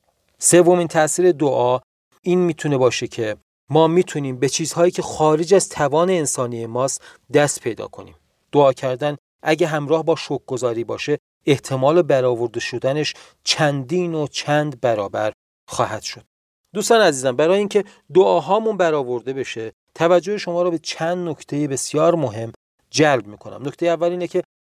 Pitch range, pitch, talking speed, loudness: 130-175 Hz, 150 Hz, 140 wpm, -19 LUFS